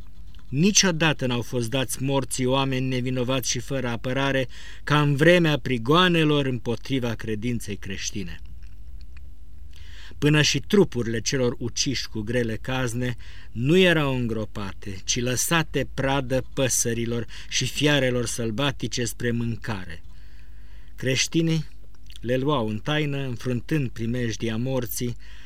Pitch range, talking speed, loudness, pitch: 105-135 Hz, 110 wpm, -24 LUFS, 120 Hz